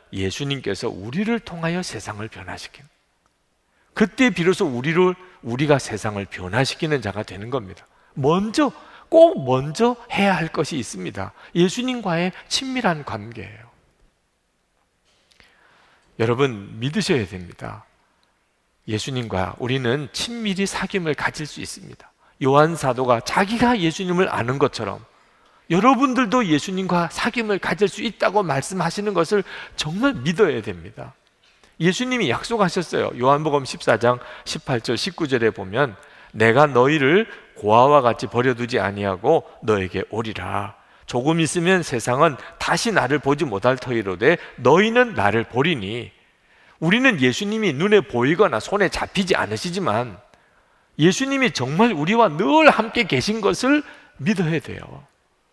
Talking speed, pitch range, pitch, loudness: 285 characters per minute, 120-200 Hz, 155 Hz, -20 LUFS